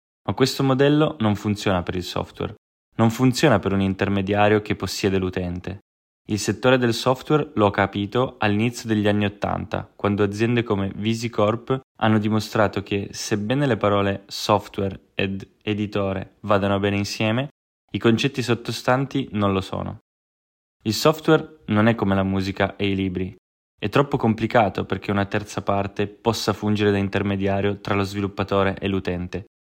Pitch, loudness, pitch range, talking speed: 105 Hz, -22 LUFS, 100-115 Hz, 150 wpm